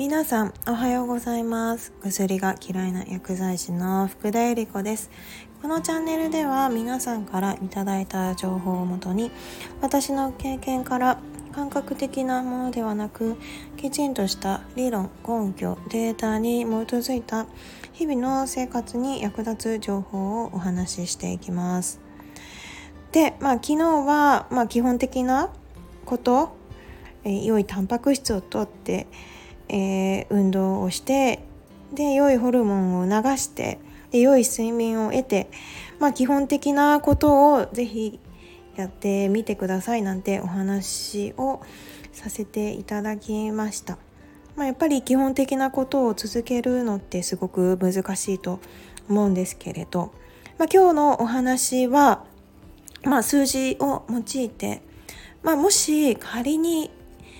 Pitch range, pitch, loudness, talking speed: 195-270 Hz, 230 Hz, -24 LUFS, 260 characters per minute